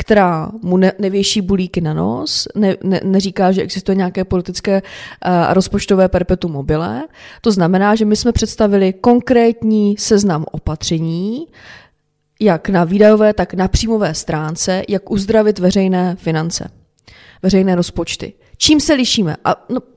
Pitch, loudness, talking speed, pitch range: 195 Hz, -15 LUFS, 135 wpm, 180-210 Hz